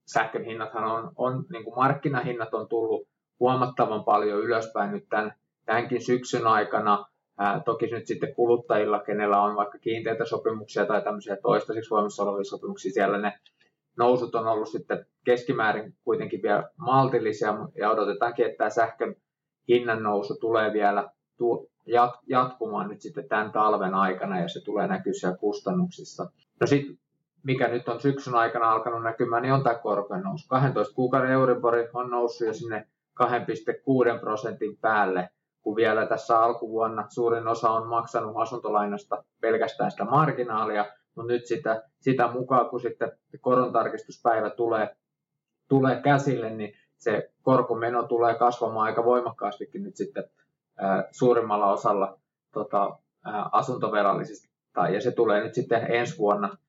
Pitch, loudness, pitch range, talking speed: 115 Hz, -26 LUFS, 110-125 Hz, 140 wpm